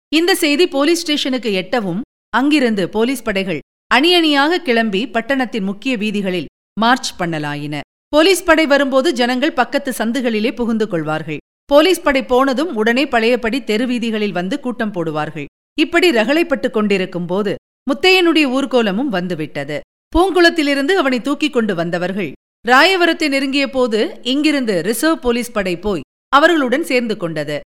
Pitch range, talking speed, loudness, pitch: 205-290 Hz, 120 wpm, -16 LUFS, 250 Hz